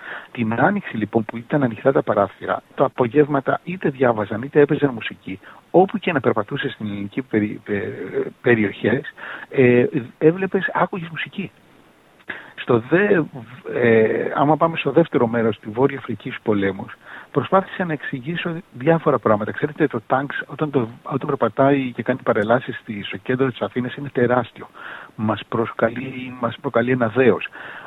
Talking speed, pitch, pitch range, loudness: 145 wpm, 130 Hz, 115-150 Hz, -20 LUFS